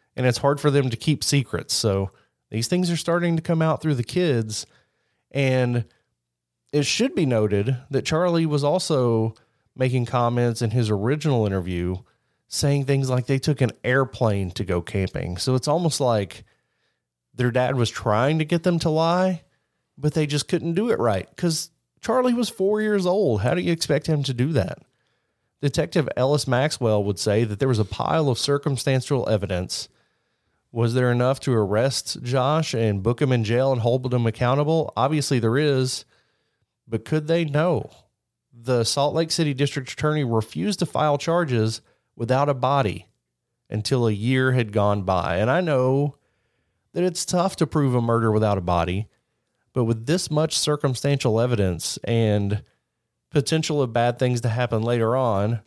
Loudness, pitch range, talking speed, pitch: -22 LUFS, 115-150 Hz, 170 wpm, 130 Hz